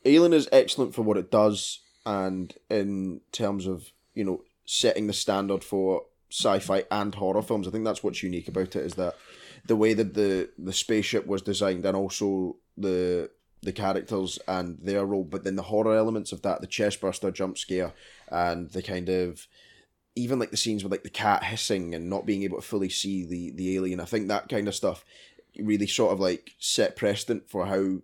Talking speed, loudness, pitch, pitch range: 200 wpm, -27 LUFS, 100 Hz, 95-105 Hz